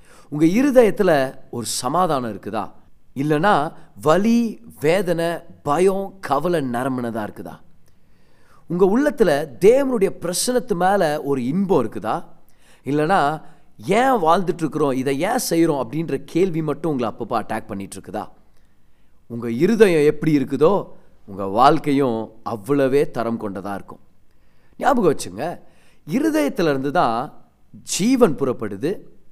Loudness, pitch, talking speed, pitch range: -20 LUFS, 145 Hz, 105 wpm, 115-185 Hz